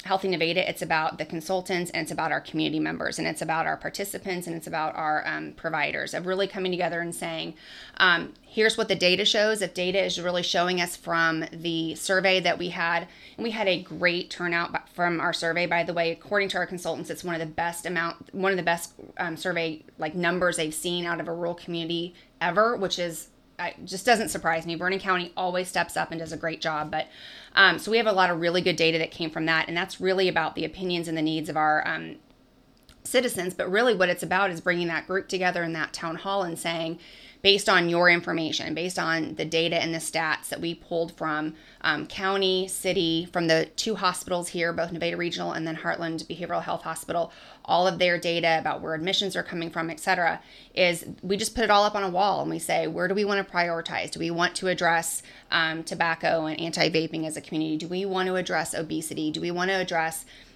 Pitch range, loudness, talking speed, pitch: 165-185 Hz, -26 LUFS, 230 wpm, 170 Hz